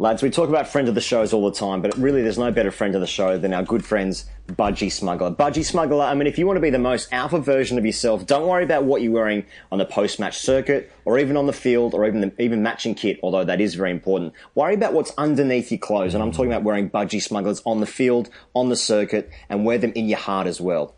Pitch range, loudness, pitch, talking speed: 100-135 Hz, -21 LUFS, 115 Hz, 270 wpm